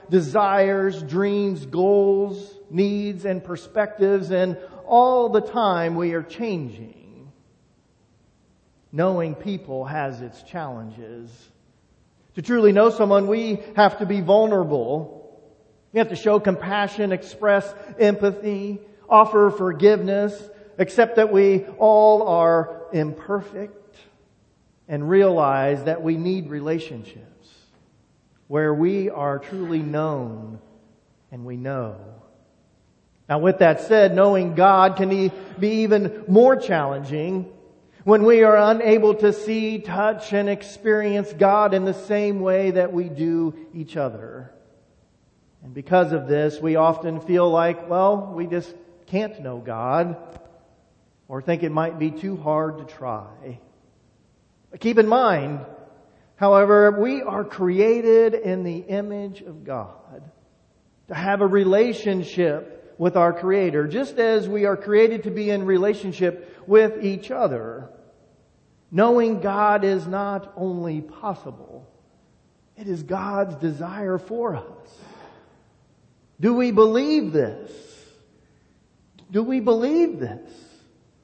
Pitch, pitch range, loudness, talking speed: 190 Hz, 160-205 Hz, -20 LUFS, 120 wpm